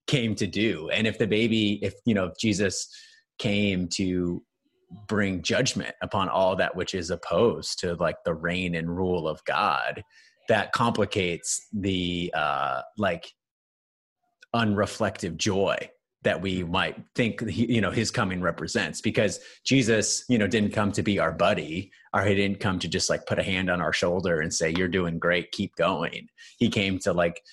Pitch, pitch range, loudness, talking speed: 100 Hz, 90-115 Hz, -26 LUFS, 175 wpm